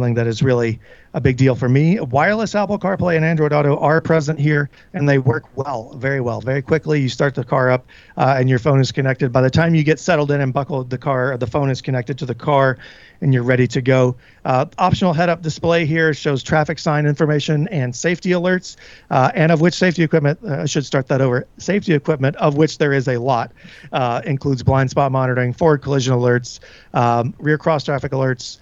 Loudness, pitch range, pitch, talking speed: -17 LUFS, 130-155 Hz, 140 Hz, 220 wpm